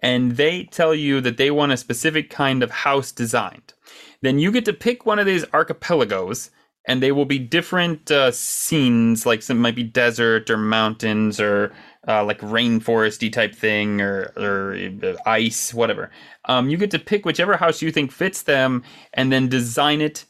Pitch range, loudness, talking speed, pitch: 115-155 Hz, -20 LUFS, 180 wpm, 130 Hz